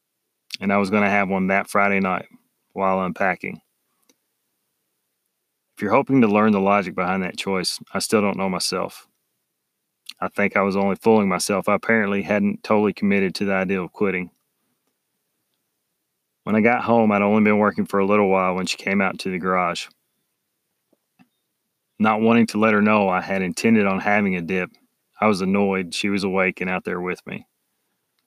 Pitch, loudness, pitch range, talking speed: 100 Hz, -20 LUFS, 95-105 Hz, 185 wpm